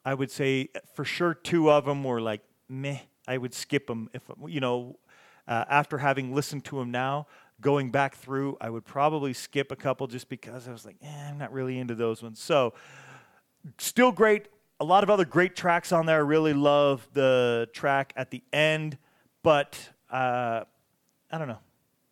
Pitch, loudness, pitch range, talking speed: 140 Hz, -27 LUFS, 130-150 Hz, 190 wpm